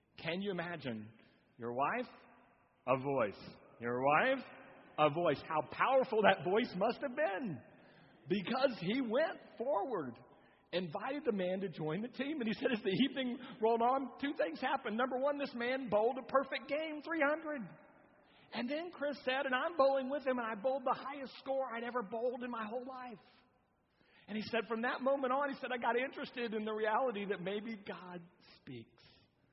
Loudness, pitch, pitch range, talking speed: -37 LUFS, 240 Hz, 200-265 Hz, 185 wpm